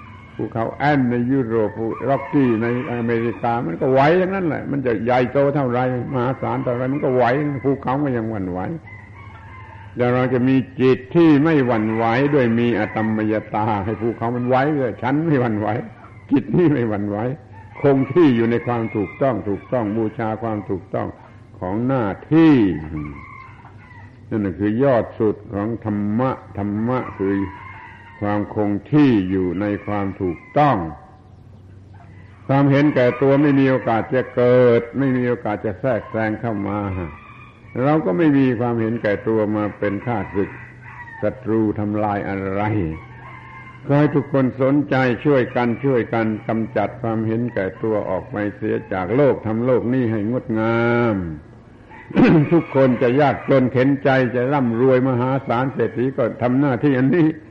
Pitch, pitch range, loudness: 115 Hz, 105-130 Hz, -19 LUFS